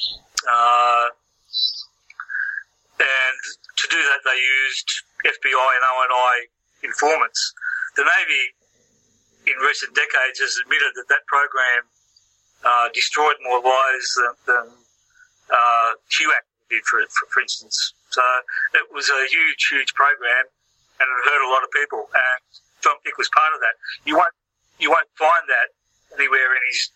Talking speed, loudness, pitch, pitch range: 140 wpm, -18 LUFS, 125 Hz, 120-140 Hz